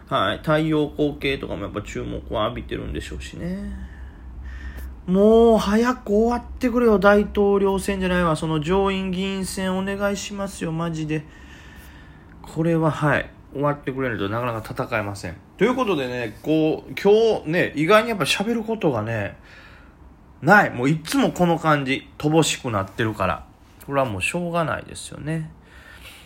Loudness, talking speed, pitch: -21 LUFS, 330 characters per minute, 155 Hz